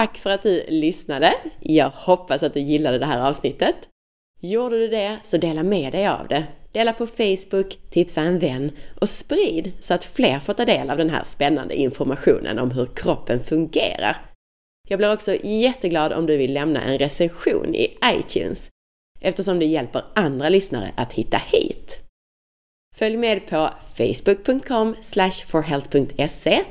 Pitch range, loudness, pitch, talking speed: 150-225 Hz, -21 LUFS, 185 Hz, 155 wpm